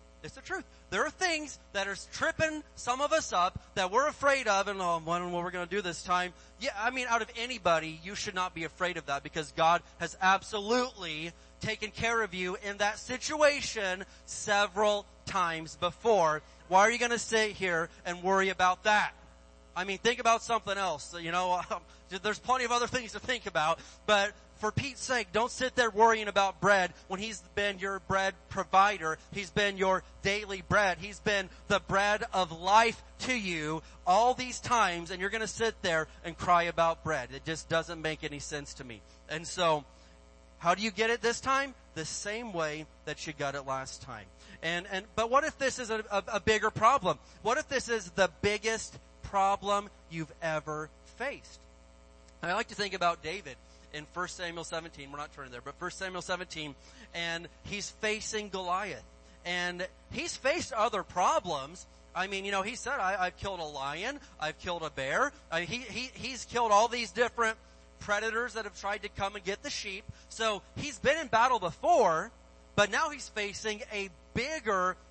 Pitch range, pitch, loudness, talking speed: 170-220 Hz, 195 Hz, -31 LUFS, 195 wpm